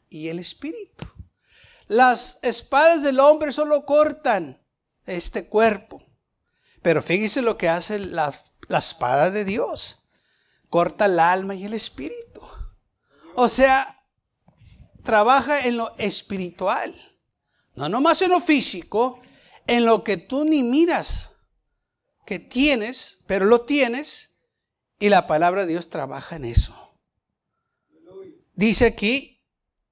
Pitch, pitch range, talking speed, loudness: 235 Hz, 195-285 Hz, 120 wpm, -20 LUFS